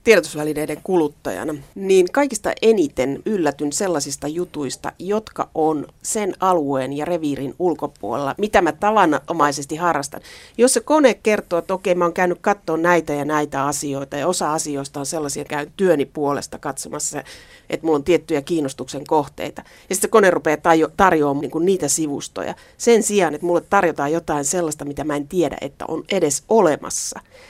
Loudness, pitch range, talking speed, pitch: -20 LUFS, 145-185 Hz, 160 wpm, 160 Hz